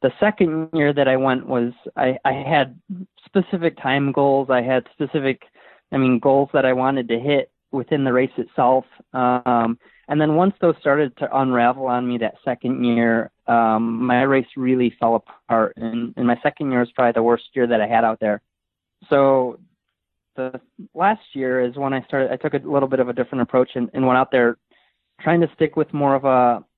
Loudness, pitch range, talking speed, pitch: -20 LUFS, 120-145 Hz, 205 wpm, 130 Hz